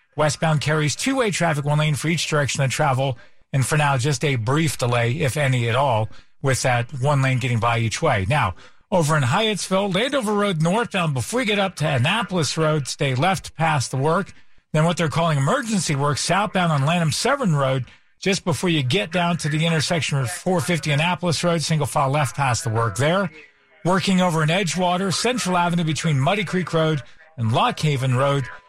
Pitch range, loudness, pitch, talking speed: 135-175 Hz, -21 LUFS, 155 Hz, 190 wpm